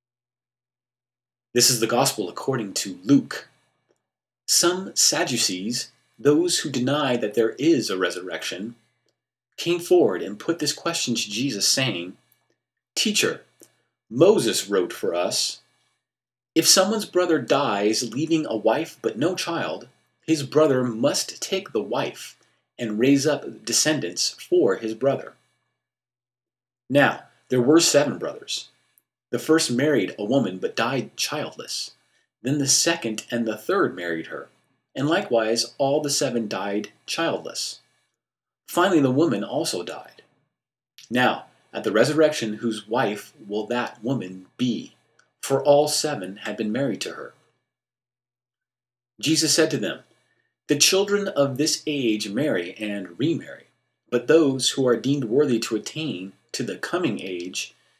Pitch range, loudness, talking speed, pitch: 115-155 Hz, -22 LUFS, 135 wpm, 125 Hz